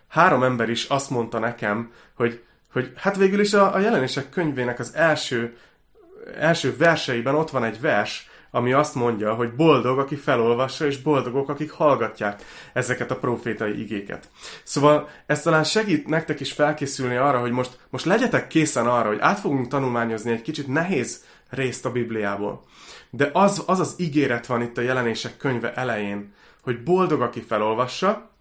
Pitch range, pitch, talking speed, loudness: 120-155 Hz, 130 Hz, 165 wpm, -22 LUFS